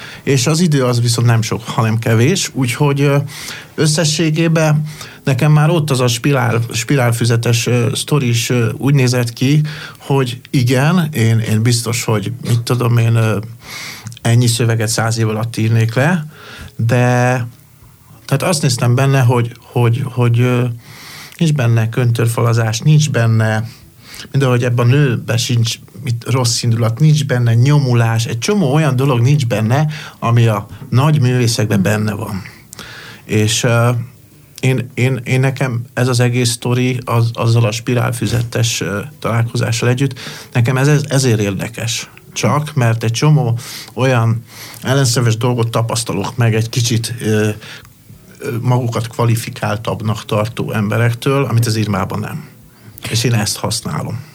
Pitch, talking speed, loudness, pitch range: 120 Hz, 135 wpm, -15 LUFS, 115-135 Hz